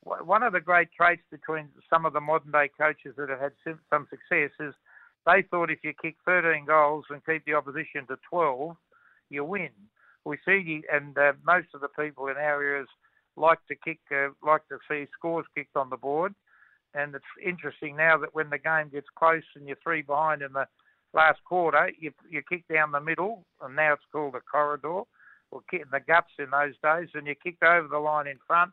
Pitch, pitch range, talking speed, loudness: 150 Hz, 145-165 Hz, 210 wpm, -27 LUFS